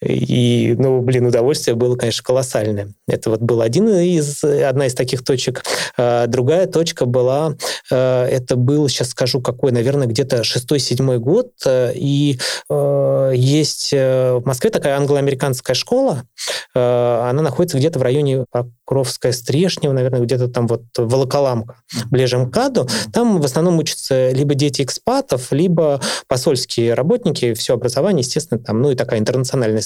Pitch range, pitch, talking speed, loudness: 125-145 Hz, 130 Hz, 135 wpm, -17 LUFS